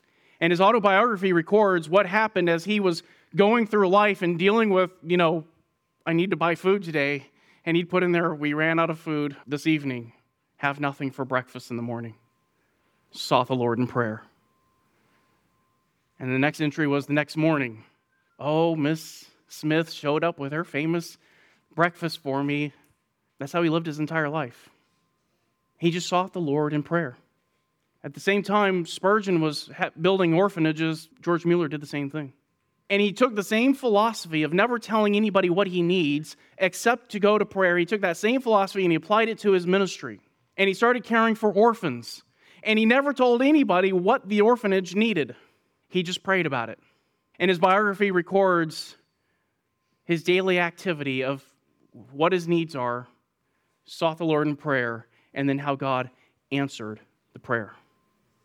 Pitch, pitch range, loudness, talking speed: 170 Hz, 145-195 Hz, -24 LUFS, 170 wpm